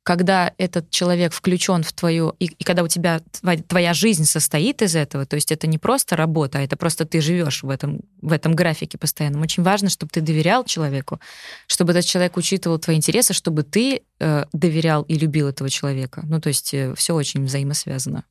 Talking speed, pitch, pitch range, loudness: 195 wpm, 165 Hz, 155-180 Hz, -20 LUFS